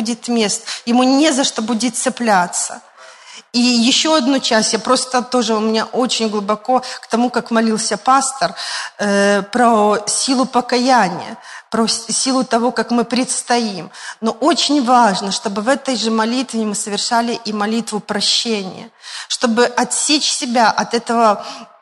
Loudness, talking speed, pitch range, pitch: -16 LUFS, 145 wpm, 220-250 Hz, 235 Hz